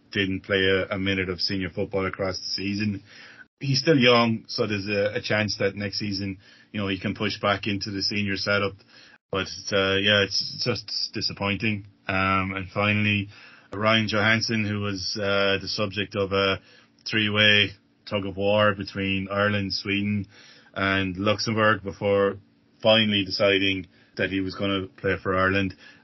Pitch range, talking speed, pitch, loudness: 95-105 Hz, 150 wpm, 100 Hz, -24 LUFS